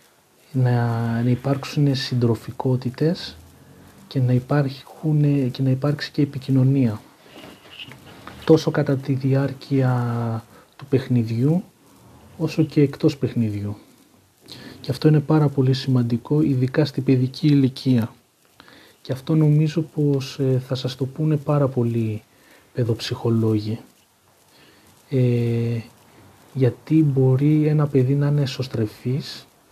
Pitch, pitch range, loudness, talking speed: 135 Hz, 120-145 Hz, -21 LUFS, 100 wpm